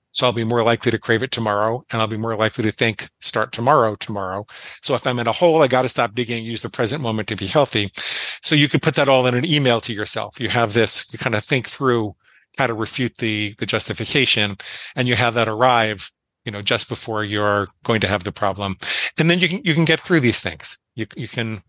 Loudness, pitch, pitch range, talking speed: -19 LUFS, 115 Hz, 110-125 Hz, 255 wpm